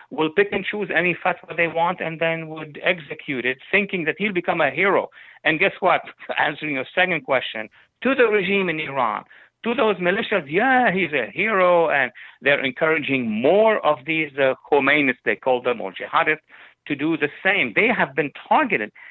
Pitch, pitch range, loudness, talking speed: 165 Hz, 150-190 Hz, -20 LUFS, 185 wpm